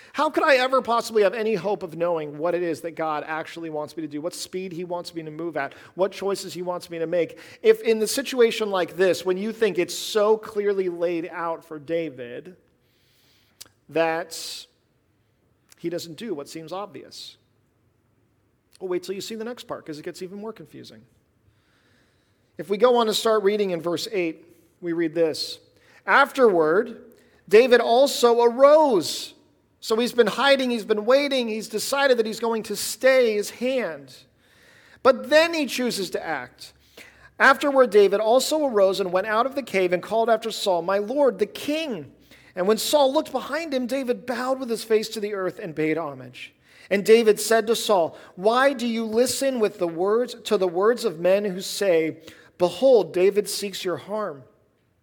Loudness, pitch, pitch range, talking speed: -22 LUFS, 200 Hz, 170-235 Hz, 185 wpm